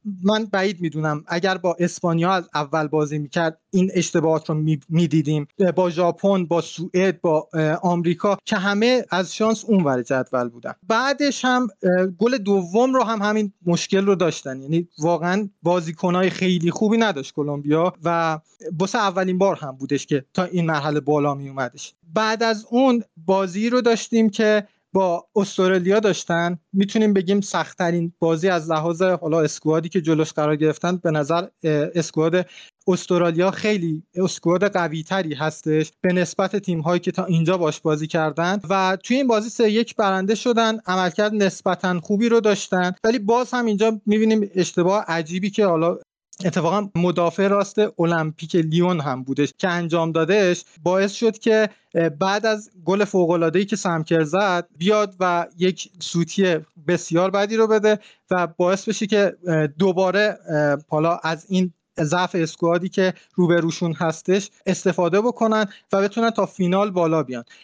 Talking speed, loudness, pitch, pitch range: 150 wpm, -21 LUFS, 180 Hz, 165-200 Hz